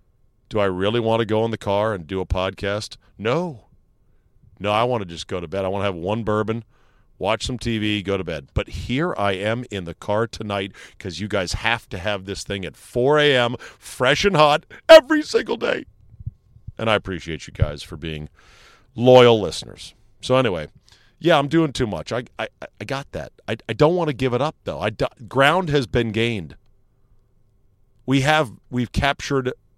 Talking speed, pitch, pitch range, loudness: 200 wpm, 110 Hz, 100-125 Hz, -21 LUFS